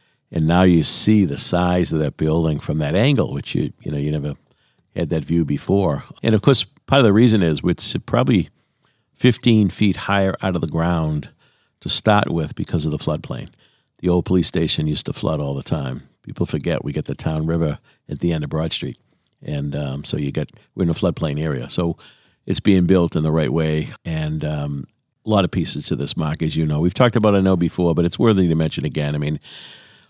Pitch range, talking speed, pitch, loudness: 75-95 Hz, 225 wpm, 85 Hz, -19 LUFS